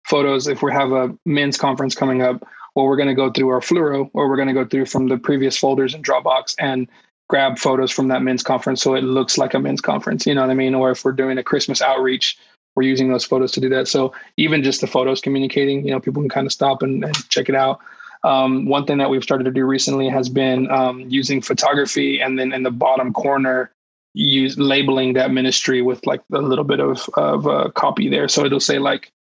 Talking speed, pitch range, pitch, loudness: 240 wpm, 130-135 Hz, 135 Hz, -18 LUFS